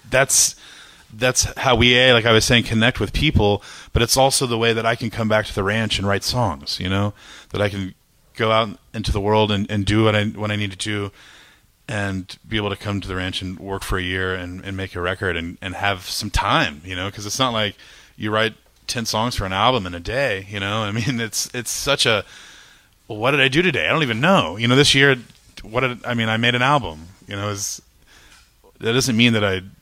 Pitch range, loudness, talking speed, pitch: 100-120 Hz, -19 LUFS, 250 wpm, 110 Hz